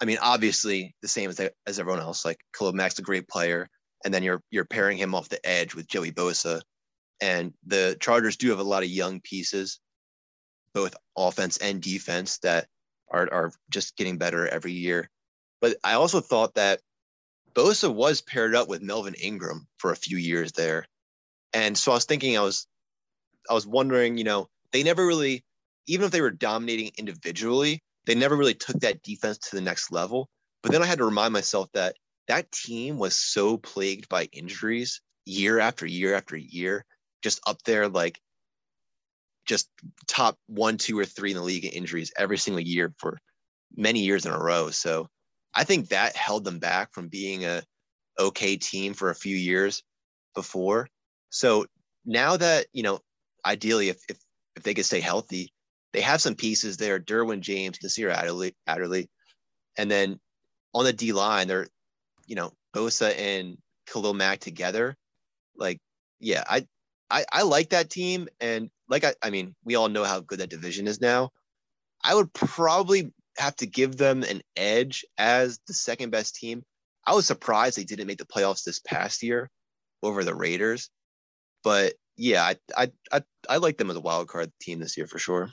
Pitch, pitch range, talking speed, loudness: 100 Hz, 90-115 Hz, 185 wpm, -26 LUFS